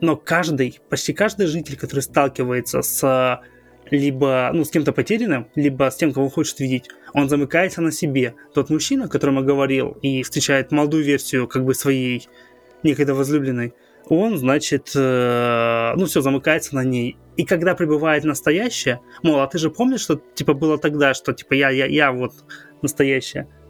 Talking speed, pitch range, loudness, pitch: 165 wpm, 130-155 Hz, -19 LUFS, 140 Hz